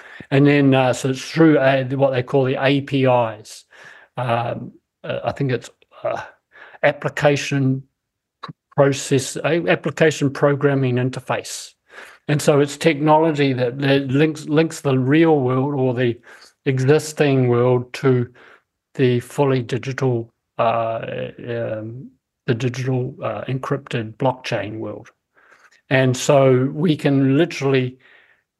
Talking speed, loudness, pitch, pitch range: 115 wpm, -19 LUFS, 135 Hz, 125-145 Hz